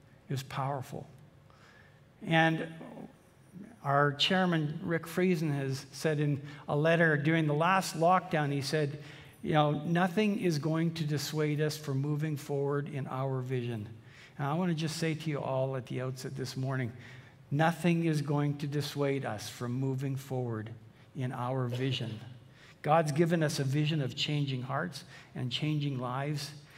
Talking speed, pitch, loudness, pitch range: 155 wpm, 145 Hz, -32 LUFS, 135-155 Hz